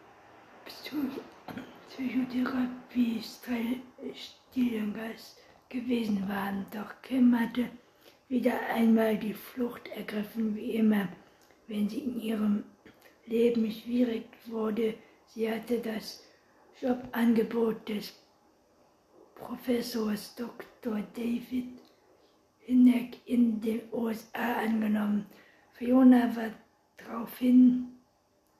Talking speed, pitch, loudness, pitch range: 80 wpm, 230 Hz, -30 LUFS, 220-250 Hz